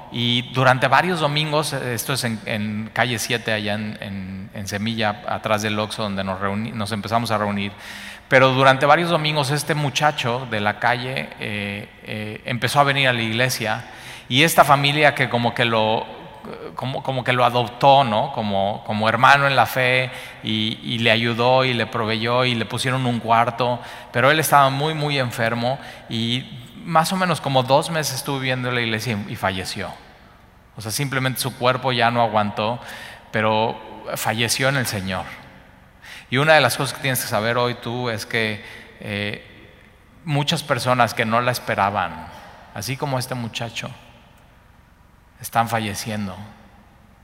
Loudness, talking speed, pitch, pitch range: -20 LUFS, 170 wpm, 120 Hz, 110-130 Hz